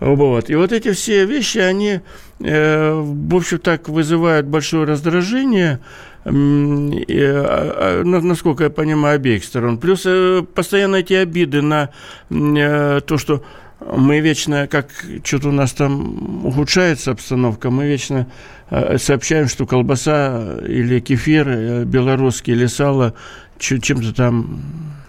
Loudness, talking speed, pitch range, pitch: -16 LUFS, 110 wpm, 135-165 Hz, 145 Hz